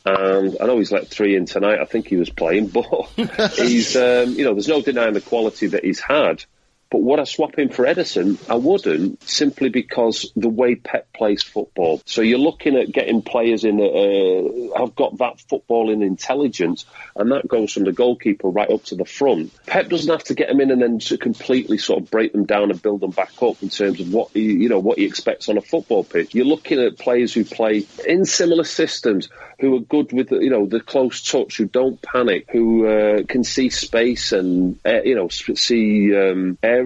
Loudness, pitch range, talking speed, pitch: -18 LUFS, 105-135 Hz, 220 wpm, 120 Hz